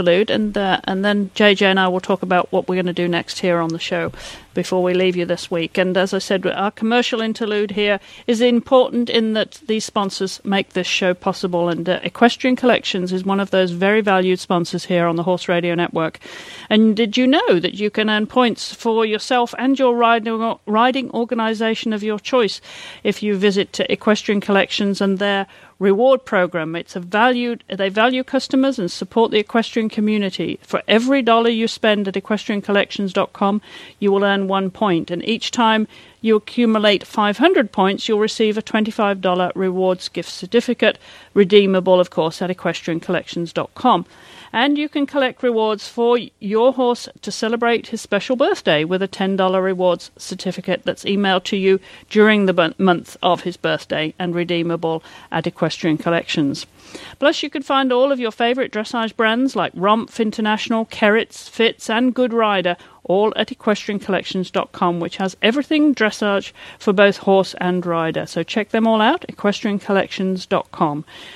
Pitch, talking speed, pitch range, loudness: 205 Hz, 170 wpm, 185-230 Hz, -18 LUFS